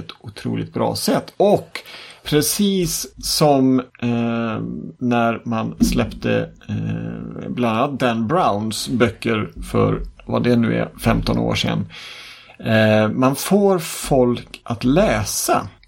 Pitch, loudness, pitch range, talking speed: 120 Hz, -19 LUFS, 115-140 Hz, 115 wpm